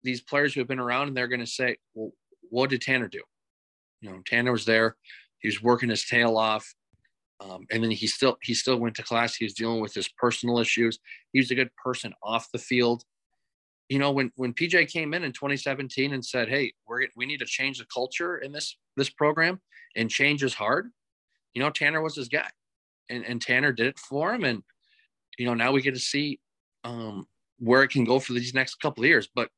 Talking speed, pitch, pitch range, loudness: 225 wpm, 125 Hz, 115-140 Hz, -26 LUFS